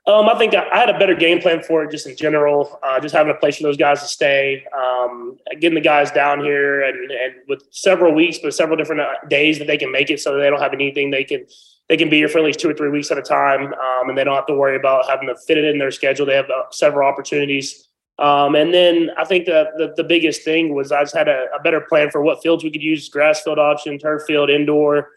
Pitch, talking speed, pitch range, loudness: 150 Hz, 275 wpm, 140-160 Hz, -16 LUFS